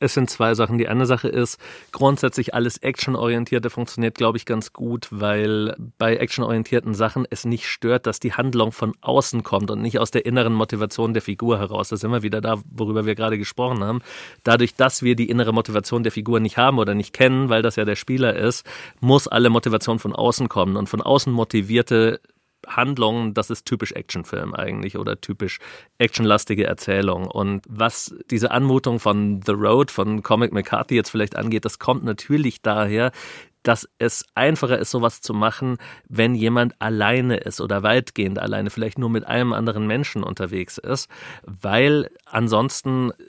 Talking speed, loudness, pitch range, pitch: 175 wpm, -21 LUFS, 110-125 Hz, 115 Hz